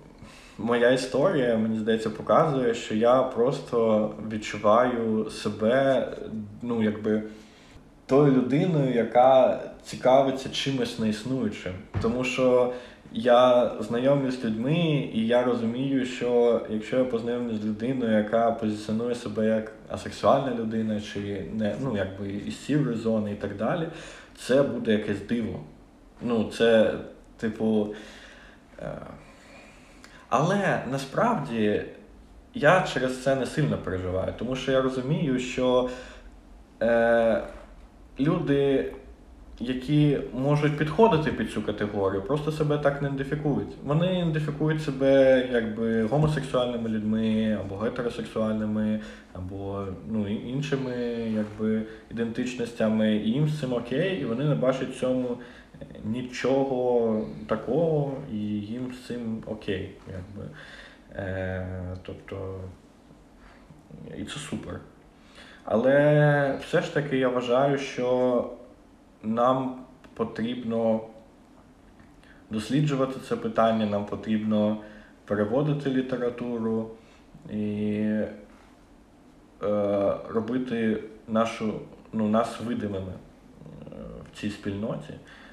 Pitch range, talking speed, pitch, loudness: 110-130 Hz, 100 wpm, 115 Hz, -26 LUFS